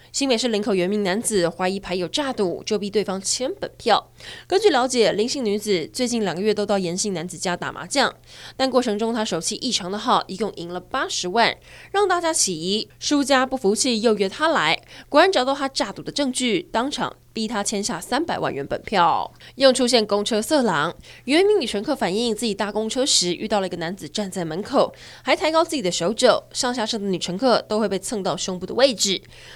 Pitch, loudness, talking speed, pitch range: 215 Hz, -21 LUFS, 315 characters per minute, 195-255 Hz